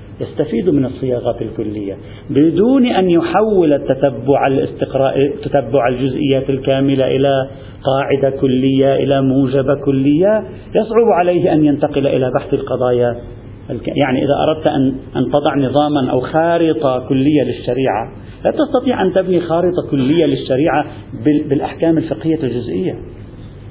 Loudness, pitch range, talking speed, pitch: -15 LUFS, 130-155 Hz, 115 wpm, 140 Hz